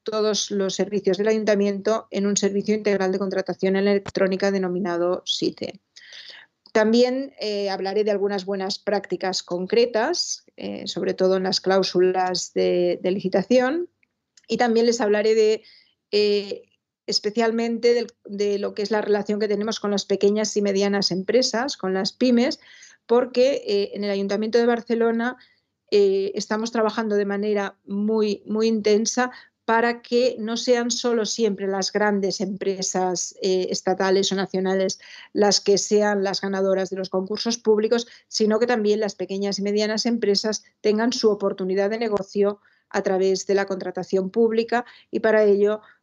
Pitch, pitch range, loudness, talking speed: 205 Hz, 195-225 Hz, -22 LUFS, 150 wpm